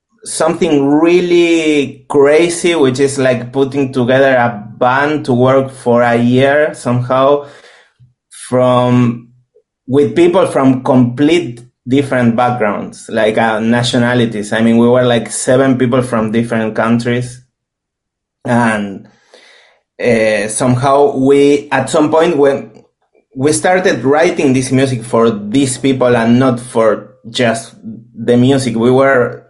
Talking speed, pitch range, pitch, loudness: 120 wpm, 120-140 Hz, 125 Hz, -12 LUFS